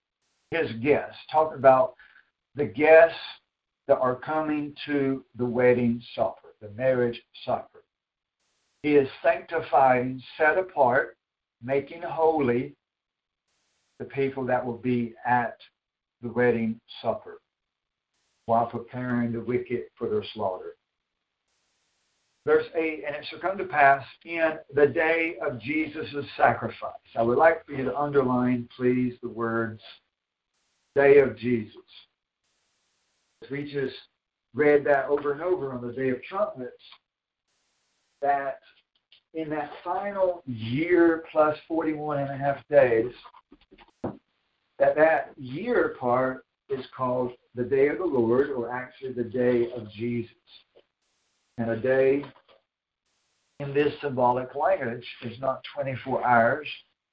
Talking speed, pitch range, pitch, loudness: 125 wpm, 125-155 Hz, 135 Hz, -25 LUFS